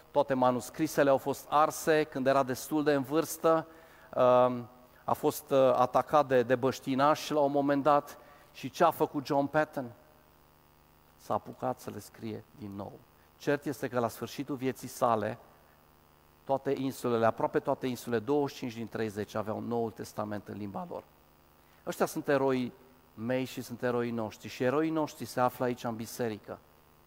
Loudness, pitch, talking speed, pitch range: -31 LUFS, 125 Hz, 155 wpm, 110-145 Hz